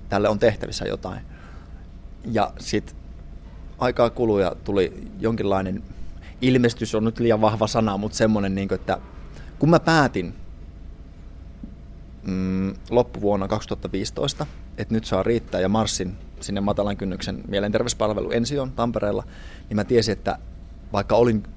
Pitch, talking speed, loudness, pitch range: 100 Hz, 120 wpm, -23 LUFS, 85-110 Hz